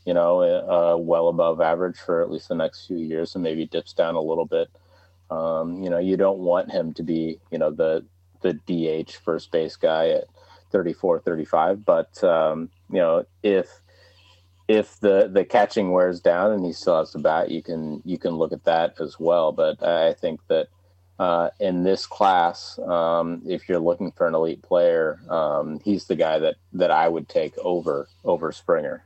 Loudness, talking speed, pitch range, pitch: -23 LUFS, 195 wpm, 85-95 Hz, 90 Hz